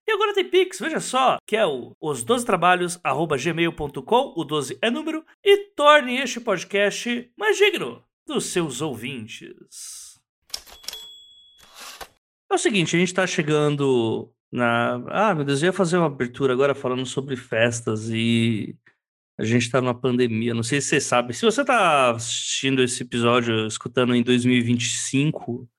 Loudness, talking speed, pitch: -22 LUFS, 150 wpm, 145 Hz